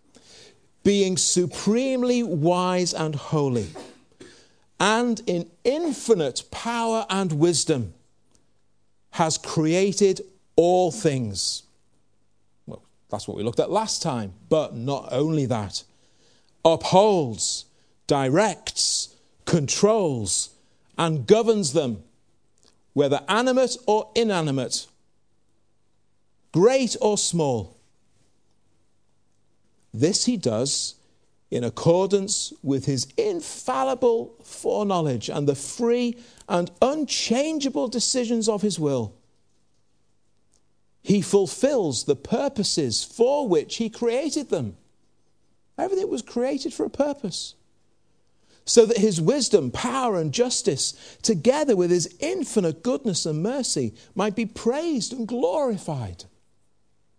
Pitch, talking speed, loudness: 175 Hz, 95 wpm, -23 LUFS